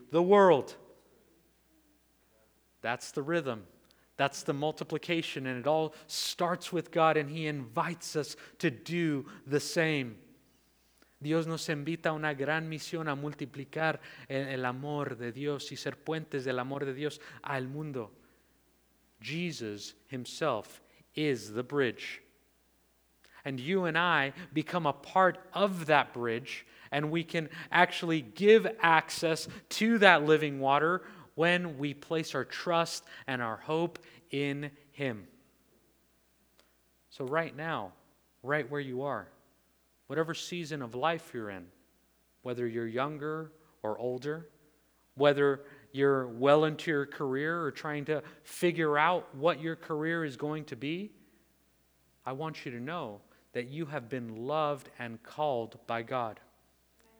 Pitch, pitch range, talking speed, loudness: 145 Hz, 125-160 Hz, 135 wpm, -32 LUFS